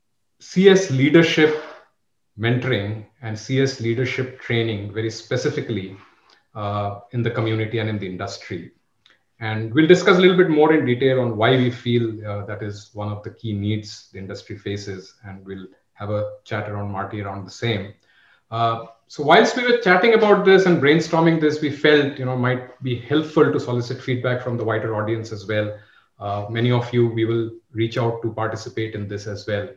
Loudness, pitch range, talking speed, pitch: -20 LUFS, 105-130 Hz, 185 wpm, 115 Hz